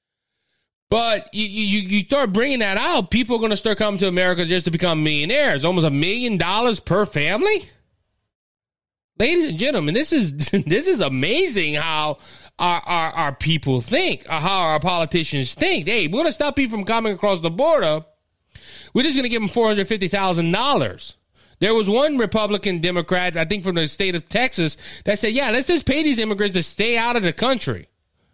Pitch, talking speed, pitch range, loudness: 200 Hz, 190 wpm, 165-230 Hz, -20 LUFS